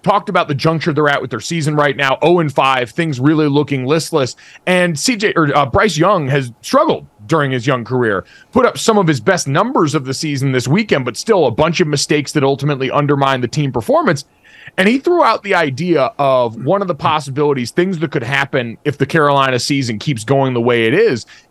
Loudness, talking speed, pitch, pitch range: -15 LUFS, 220 wpm, 145 Hz, 135-170 Hz